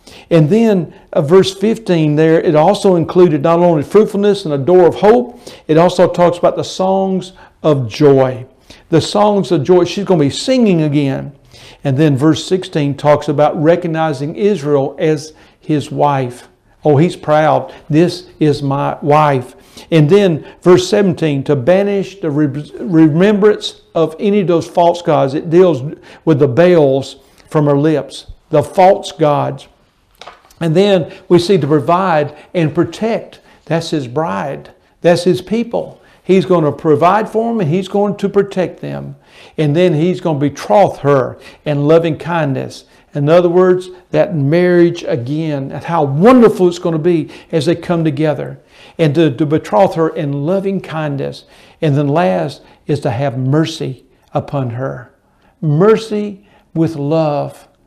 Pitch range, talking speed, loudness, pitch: 150-185 Hz, 155 wpm, -13 LUFS, 165 Hz